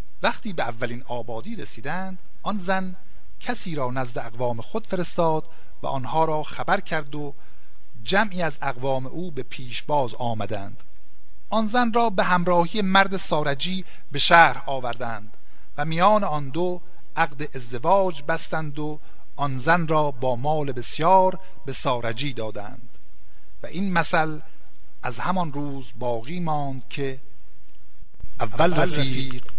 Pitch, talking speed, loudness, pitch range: 150 Hz, 130 wpm, -23 LUFS, 125-180 Hz